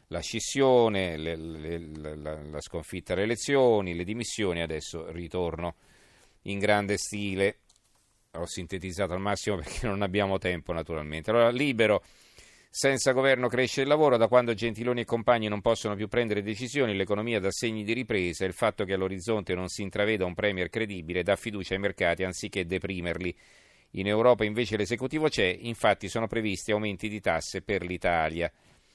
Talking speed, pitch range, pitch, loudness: 155 wpm, 90-115 Hz, 100 Hz, -28 LUFS